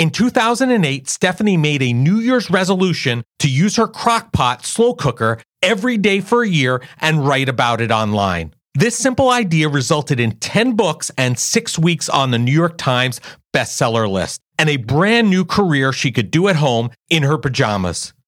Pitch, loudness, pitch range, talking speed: 150 Hz, -16 LUFS, 125-200 Hz, 180 wpm